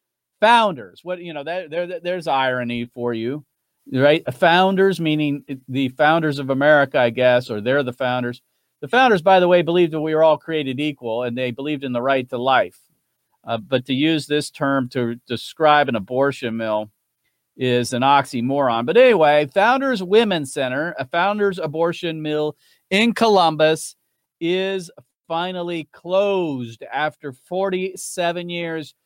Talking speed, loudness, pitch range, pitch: 150 wpm, -19 LUFS, 130-175 Hz, 150 Hz